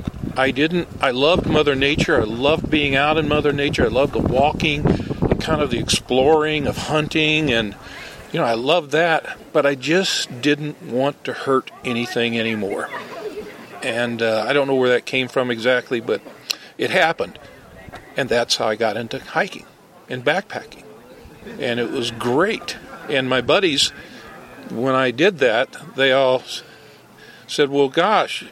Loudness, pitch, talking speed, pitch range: -19 LUFS, 140 Hz, 160 wpm, 125-150 Hz